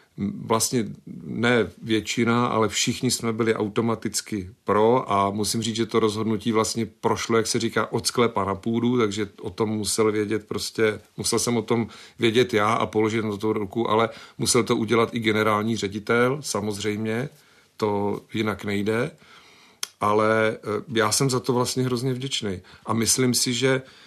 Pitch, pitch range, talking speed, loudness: 110 Hz, 105-120 Hz, 160 wpm, -23 LUFS